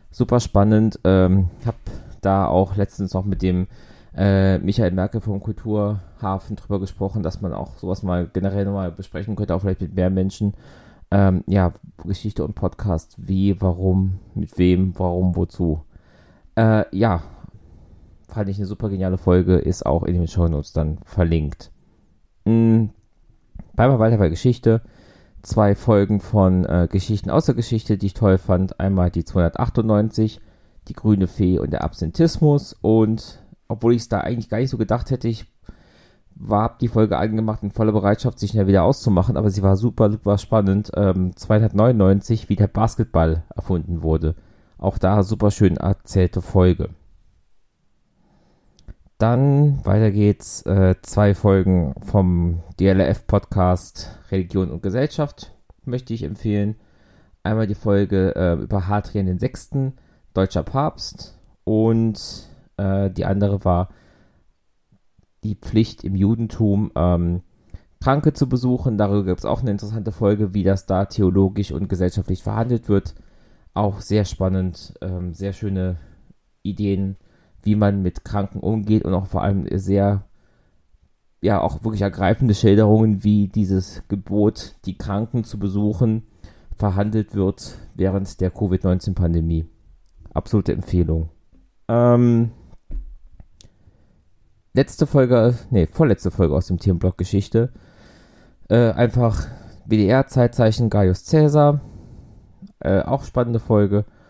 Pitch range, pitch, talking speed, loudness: 90-110 Hz, 100 Hz, 135 wpm, -20 LUFS